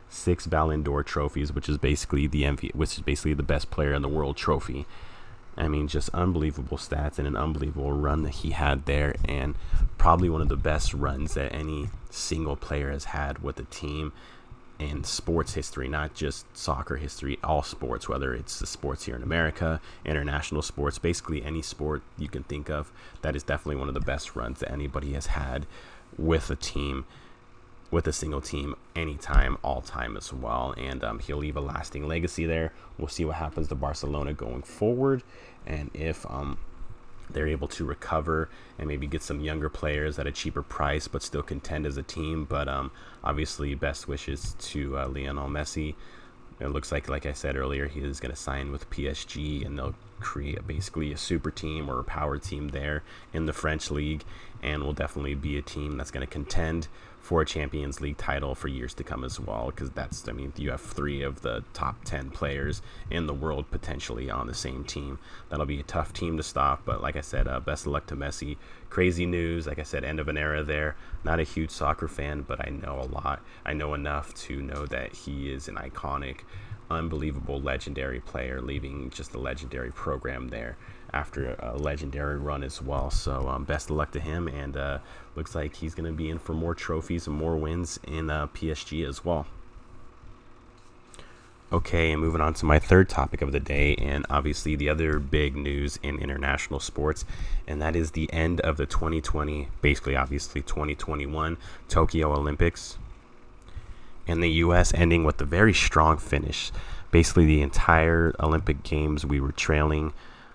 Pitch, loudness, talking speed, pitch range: 75 Hz, -29 LUFS, 195 wpm, 70-80 Hz